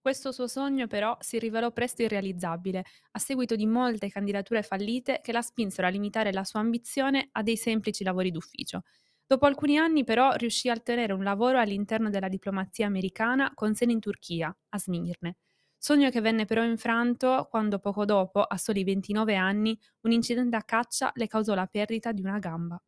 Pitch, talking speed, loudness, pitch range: 220 Hz, 180 wpm, -28 LUFS, 200-240 Hz